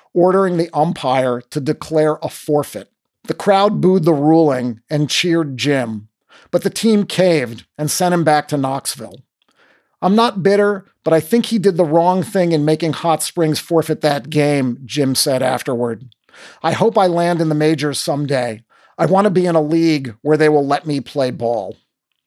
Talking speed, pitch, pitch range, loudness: 185 wpm, 155 Hz, 140-175 Hz, -16 LUFS